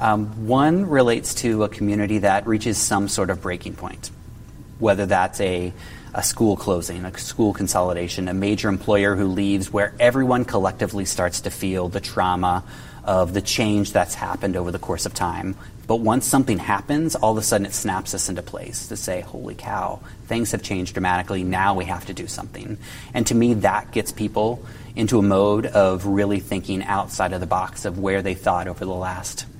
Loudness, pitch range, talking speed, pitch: -22 LUFS, 95-110 Hz, 195 wpm, 100 Hz